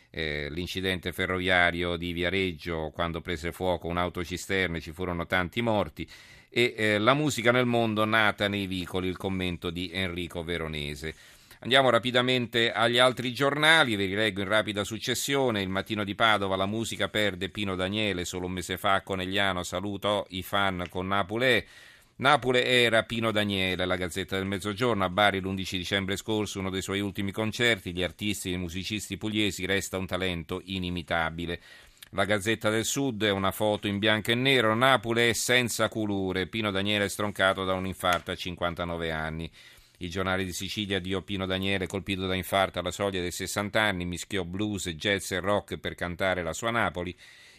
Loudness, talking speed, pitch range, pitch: -27 LUFS, 170 wpm, 90-105 Hz, 95 Hz